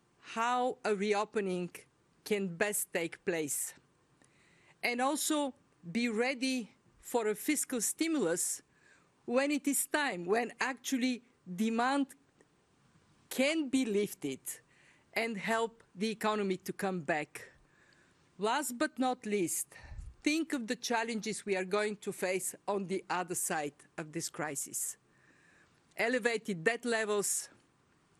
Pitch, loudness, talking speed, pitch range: 220 Hz, -34 LUFS, 115 wpm, 190-250 Hz